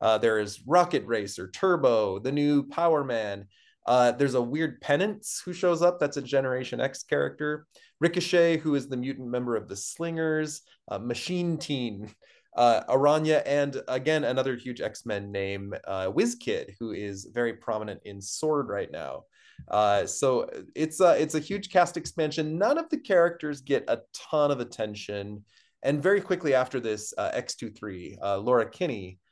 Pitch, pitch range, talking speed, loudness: 140 Hz, 110-160 Hz, 165 wpm, -27 LUFS